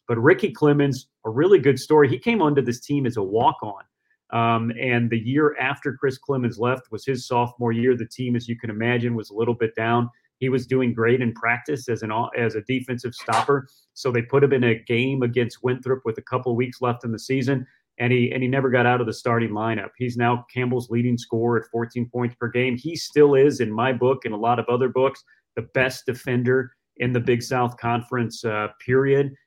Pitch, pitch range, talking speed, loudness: 125 Hz, 120-130 Hz, 225 wpm, -22 LUFS